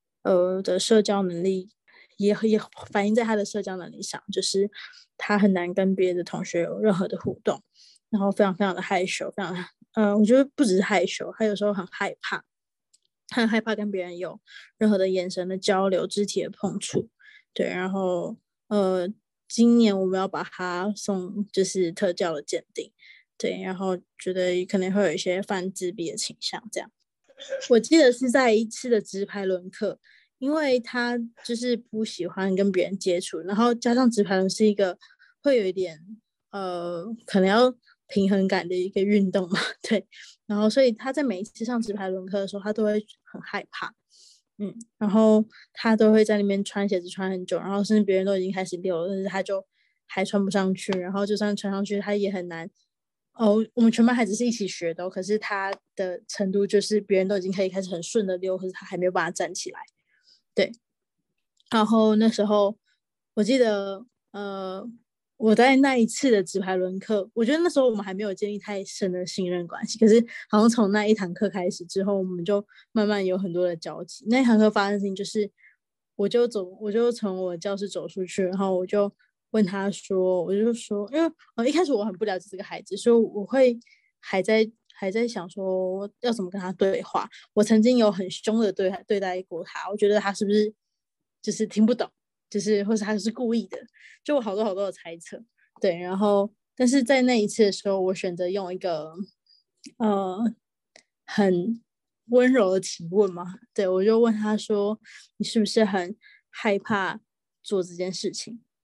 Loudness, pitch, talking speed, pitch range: -25 LUFS, 205 Hz, 280 characters per minute, 190-220 Hz